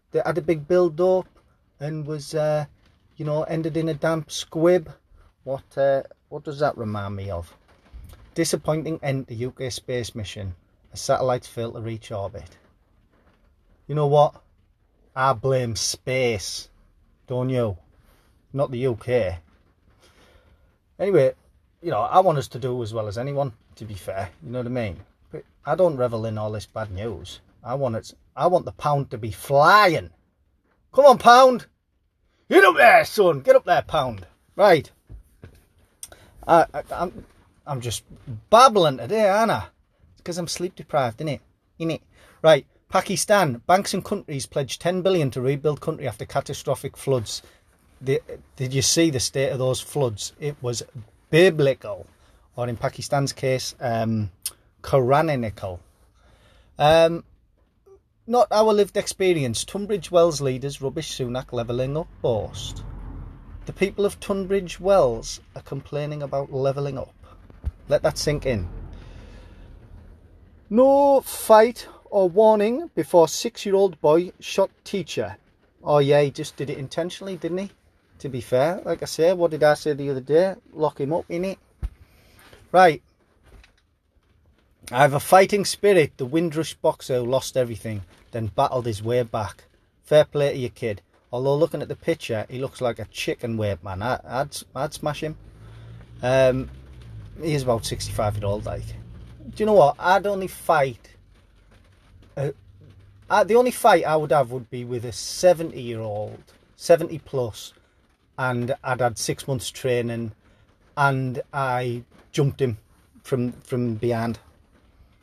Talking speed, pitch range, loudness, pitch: 150 wpm, 100-155 Hz, -22 LUFS, 125 Hz